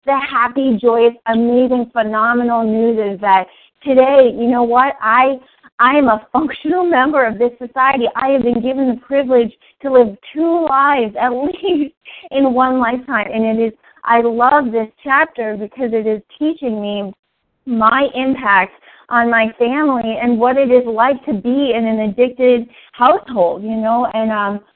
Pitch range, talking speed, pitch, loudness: 225-270 Hz, 160 wpm, 245 Hz, -14 LUFS